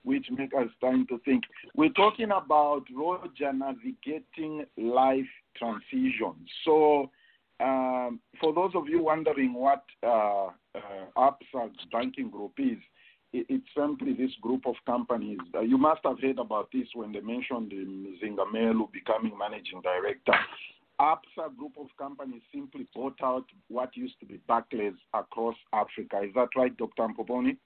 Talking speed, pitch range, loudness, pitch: 140 wpm, 115-165 Hz, -29 LUFS, 130 Hz